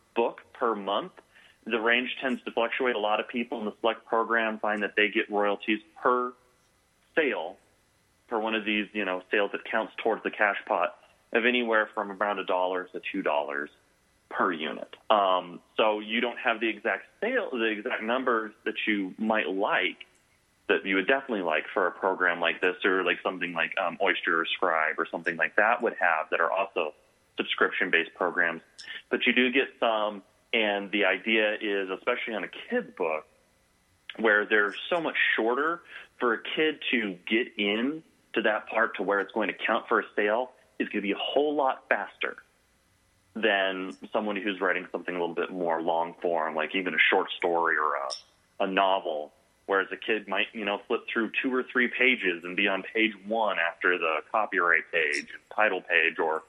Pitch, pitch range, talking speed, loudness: 105 Hz, 90-115 Hz, 190 wpm, -27 LUFS